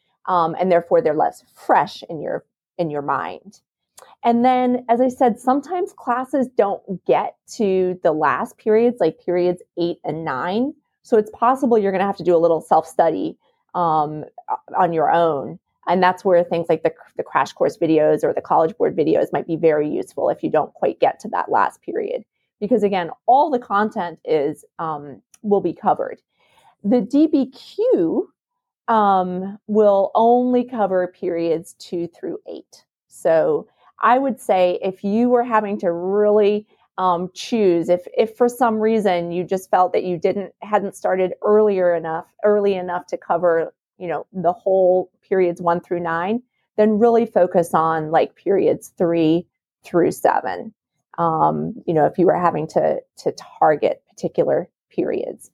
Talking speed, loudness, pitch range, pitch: 165 wpm, -19 LUFS, 175-240 Hz, 195 Hz